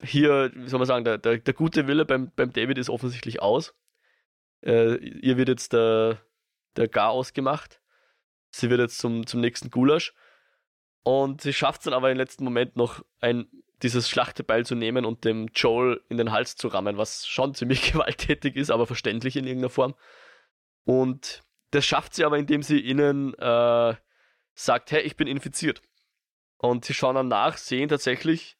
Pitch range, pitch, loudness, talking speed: 120-140 Hz, 130 Hz, -25 LUFS, 180 wpm